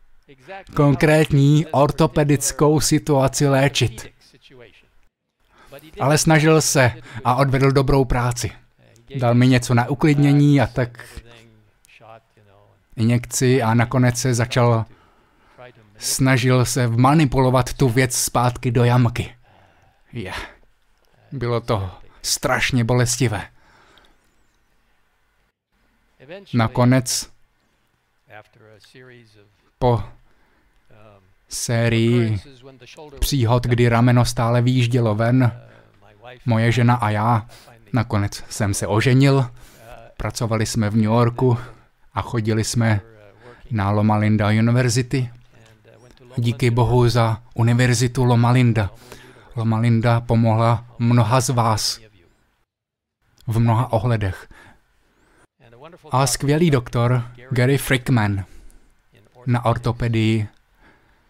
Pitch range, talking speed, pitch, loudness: 115-130 Hz, 85 wpm, 120 Hz, -19 LUFS